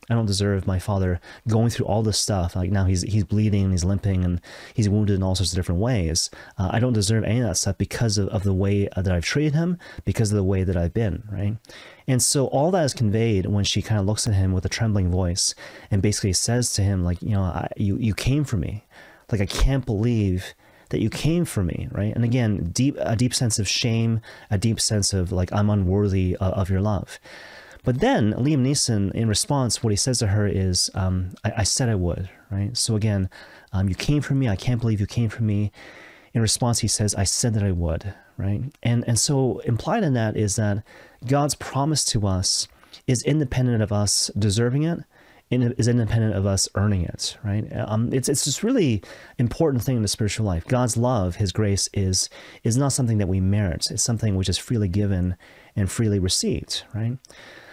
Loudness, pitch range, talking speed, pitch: -23 LUFS, 95-120 Hz, 220 wpm, 105 Hz